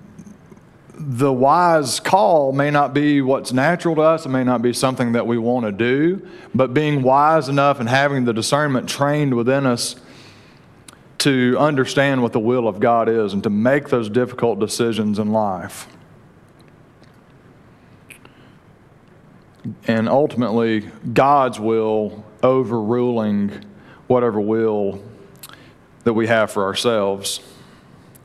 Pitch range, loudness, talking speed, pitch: 115-145 Hz, -18 LUFS, 125 wpm, 125 Hz